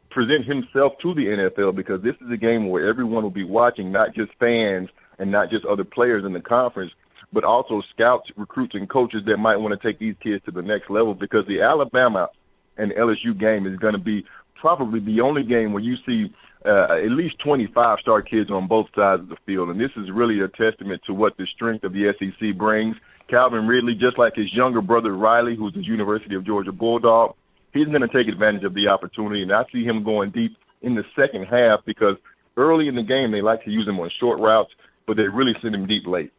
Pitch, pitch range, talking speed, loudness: 110 Hz, 105-120 Hz, 230 wpm, -21 LUFS